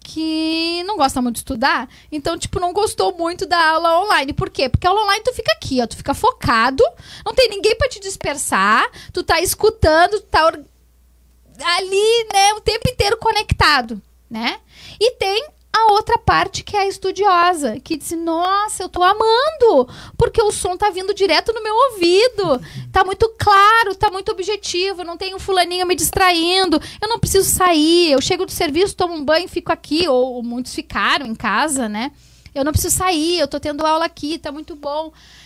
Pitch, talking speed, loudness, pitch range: 365 Hz, 190 wpm, -17 LUFS, 315-415 Hz